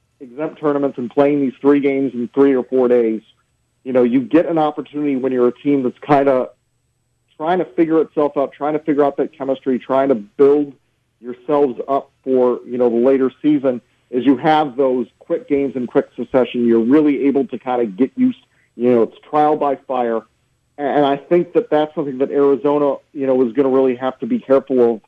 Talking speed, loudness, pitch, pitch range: 215 wpm, -17 LUFS, 135 Hz, 125-145 Hz